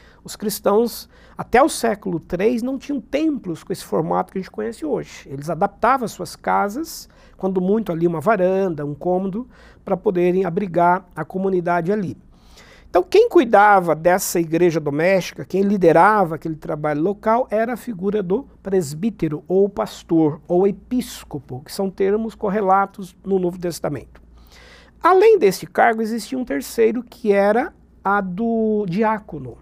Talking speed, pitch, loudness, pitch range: 145 wpm, 195 Hz, -19 LUFS, 175-225 Hz